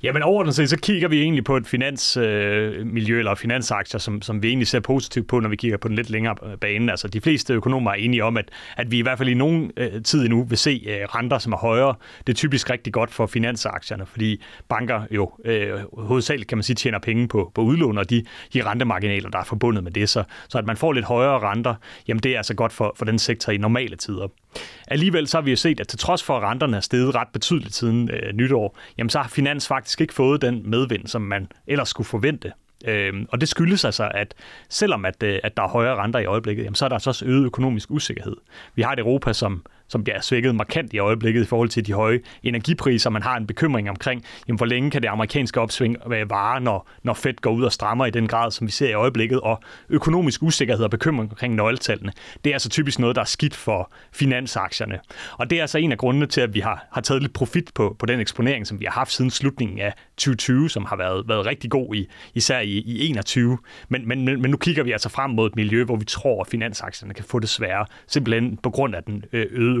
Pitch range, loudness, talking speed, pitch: 110-130 Hz, -22 LUFS, 250 wpm, 120 Hz